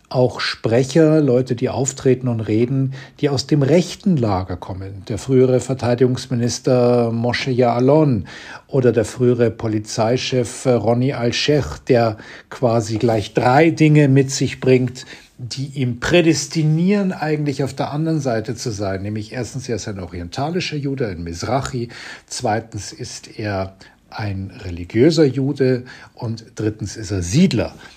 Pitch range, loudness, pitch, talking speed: 115-140 Hz, -18 LUFS, 125 Hz, 135 wpm